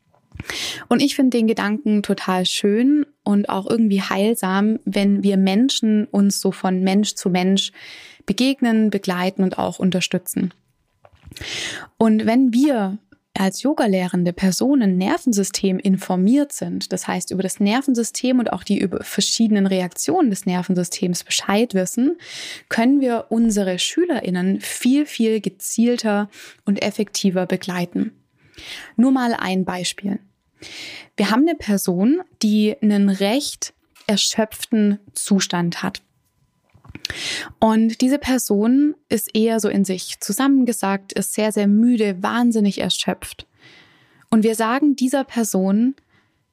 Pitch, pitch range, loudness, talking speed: 210 Hz, 195-240 Hz, -19 LUFS, 120 wpm